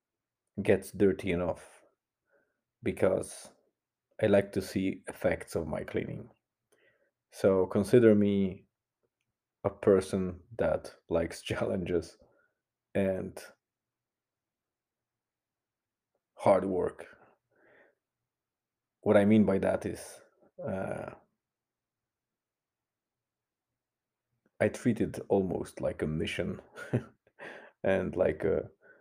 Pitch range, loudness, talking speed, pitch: 95-105 Hz, -30 LUFS, 85 wpm, 100 Hz